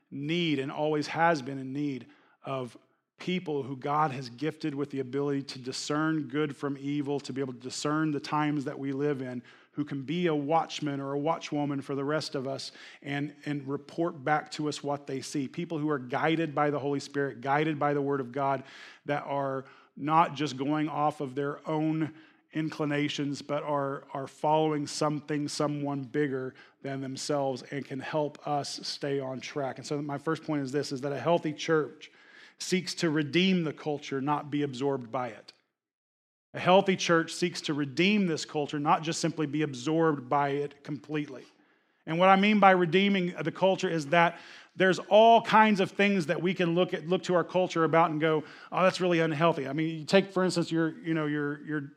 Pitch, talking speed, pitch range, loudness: 150 Hz, 200 wpm, 140-165 Hz, -29 LUFS